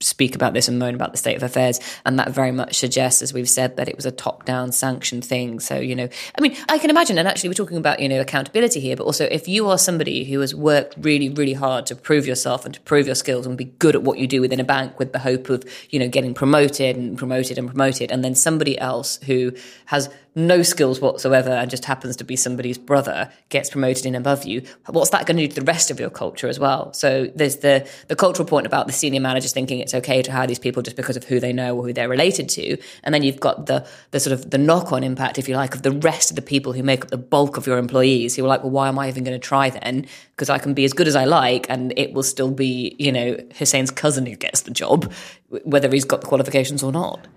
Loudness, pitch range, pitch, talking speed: -20 LUFS, 125-145 Hz, 135 Hz, 275 wpm